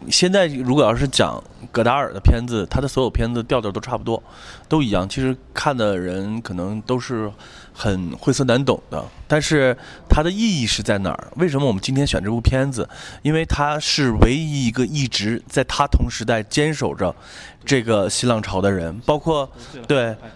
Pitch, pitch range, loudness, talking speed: 120 Hz, 110-140 Hz, -20 LUFS, 275 characters per minute